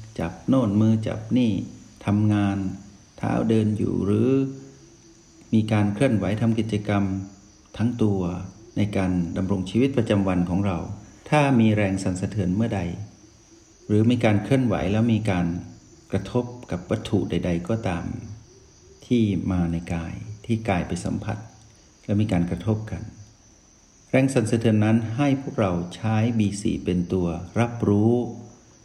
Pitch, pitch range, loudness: 105 Hz, 95-115 Hz, -24 LUFS